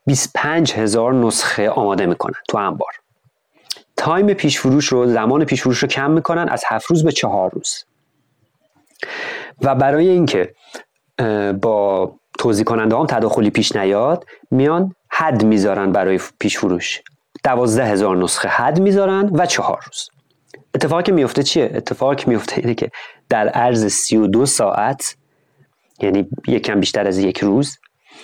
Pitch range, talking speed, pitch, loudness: 110-165 Hz, 140 wpm, 135 Hz, -17 LUFS